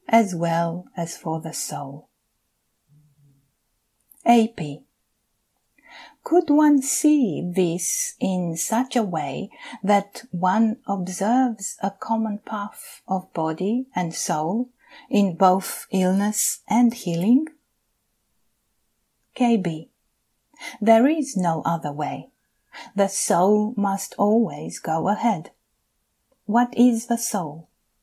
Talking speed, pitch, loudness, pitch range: 100 wpm, 205 Hz, -22 LUFS, 175-235 Hz